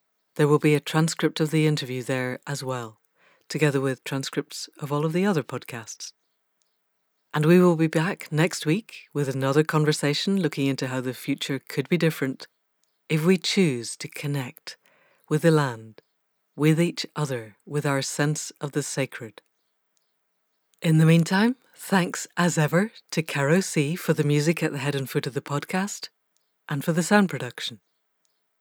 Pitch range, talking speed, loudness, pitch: 140-165 Hz, 170 wpm, -24 LUFS, 150 Hz